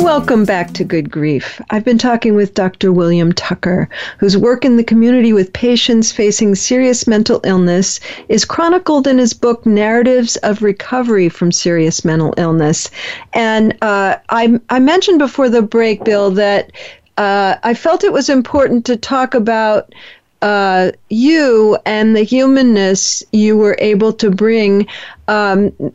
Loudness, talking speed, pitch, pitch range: -12 LUFS, 150 wpm, 220 Hz, 195-245 Hz